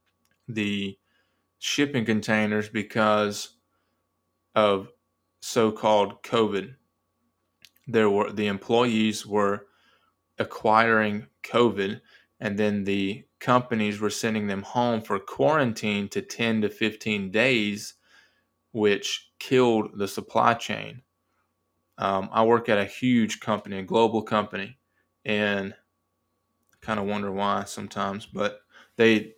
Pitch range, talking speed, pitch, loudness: 100-110 Hz, 105 wpm, 105 Hz, -25 LUFS